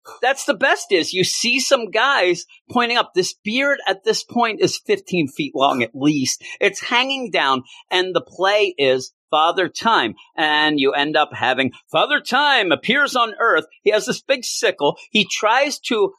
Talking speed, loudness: 180 wpm, -18 LUFS